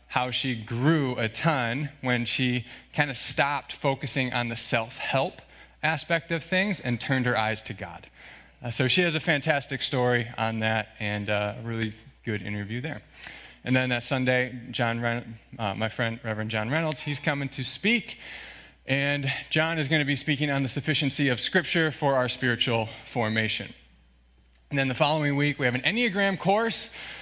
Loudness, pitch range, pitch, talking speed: -27 LUFS, 115-150 Hz, 130 Hz, 180 wpm